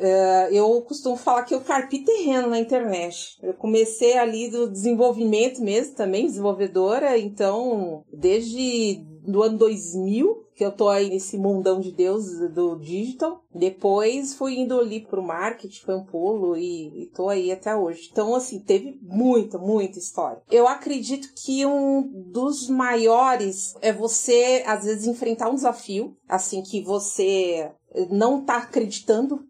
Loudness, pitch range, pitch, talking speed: -23 LUFS, 195-255 Hz, 225 Hz, 150 wpm